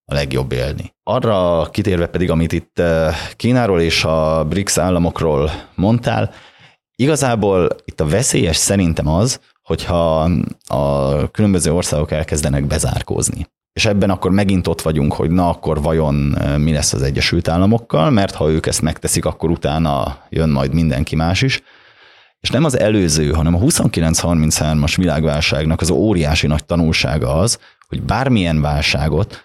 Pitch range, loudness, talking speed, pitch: 75-90 Hz, -16 LUFS, 140 wpm, 80 Hz